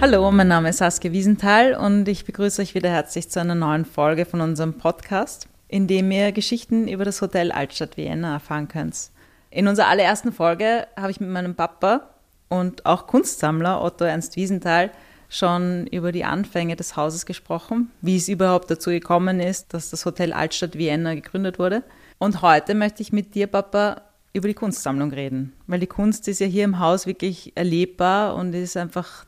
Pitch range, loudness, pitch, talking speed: 170-200 Hz, -21 LUFS, 180 Hz, 180 wpm